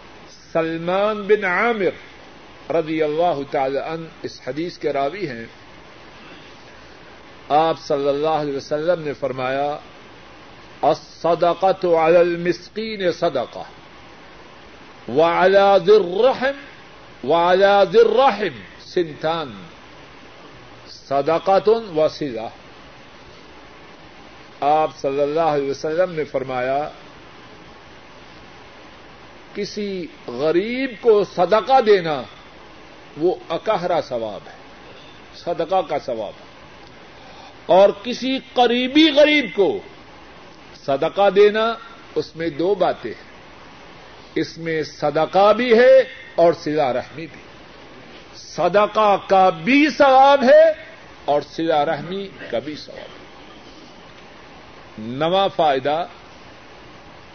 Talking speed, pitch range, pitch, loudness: 90 wpm, 155-220 Hz, 175 Hz, -18 LUFS